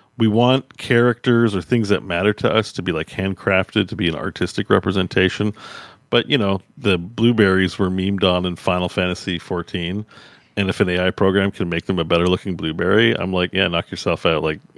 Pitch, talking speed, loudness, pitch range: 95 Hz, 200 wpm, -19 LUFS, 90-105 Hz